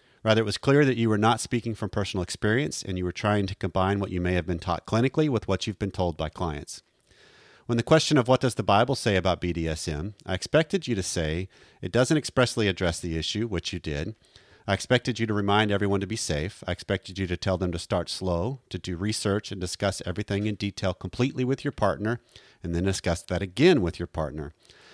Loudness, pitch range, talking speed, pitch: -26 LUFS, 90-115 Hz, 230 wpm, 100 Hz